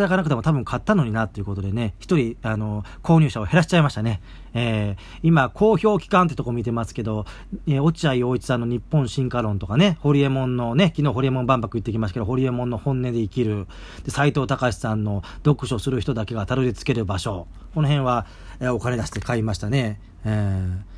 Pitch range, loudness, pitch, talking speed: 105-140 Hz, -22 LUFS, 120 Hz, 430 characters per minute